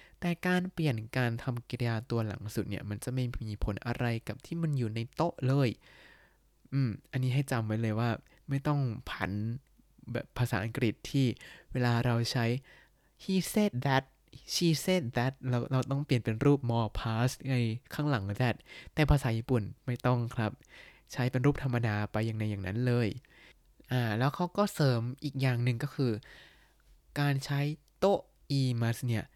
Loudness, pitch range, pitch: -32 LUFS, 115-140 Hz, 125 Hz